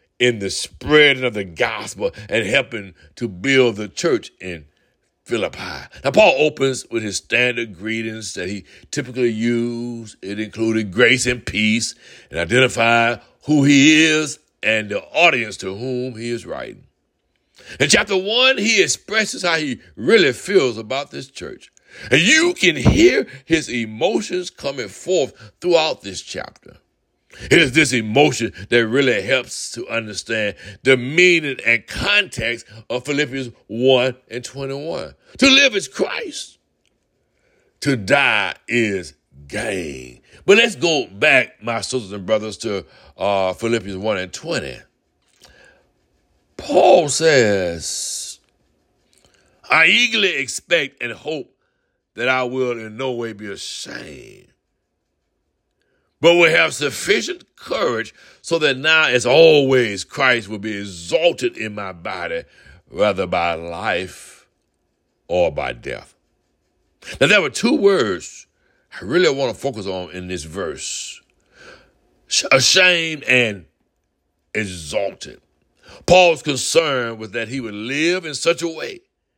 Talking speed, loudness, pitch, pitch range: 130 wpm, -17 LUFS, 125 Hz, 110-160 Hz